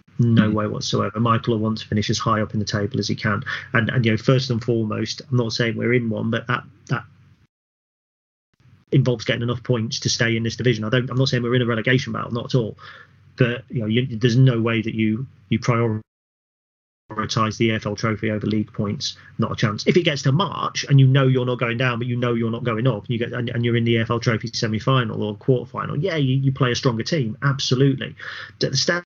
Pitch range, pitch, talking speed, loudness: 110-130 Hz, 120 Hz, 245 wpm, -21 LUFS